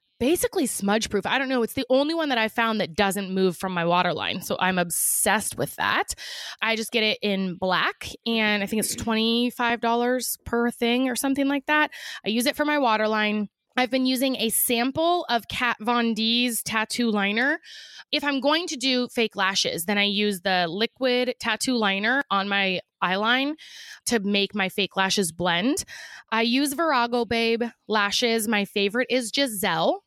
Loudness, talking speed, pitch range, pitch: -23 LUFS, 180 wpm, 205-255 Hz, 230 Hz